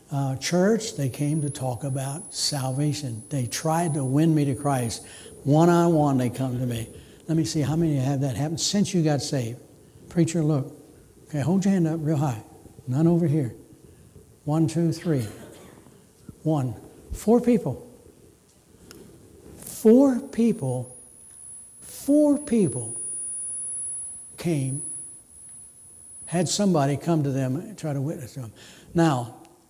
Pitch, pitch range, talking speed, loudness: 150 Hz, 130-165 Hz, 135 wpm, -24 LUFS